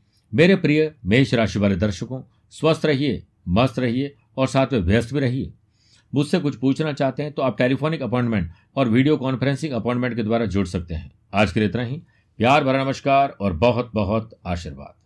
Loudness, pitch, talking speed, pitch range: -21 LUFS, 125 Hz, 185 wpm, 105-140 Hz